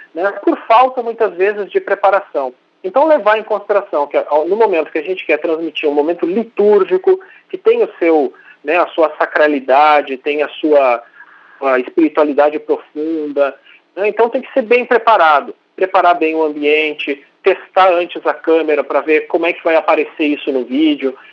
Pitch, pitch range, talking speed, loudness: 175 Hz, 150-225 Hz, 170 wpm, -14 LUFS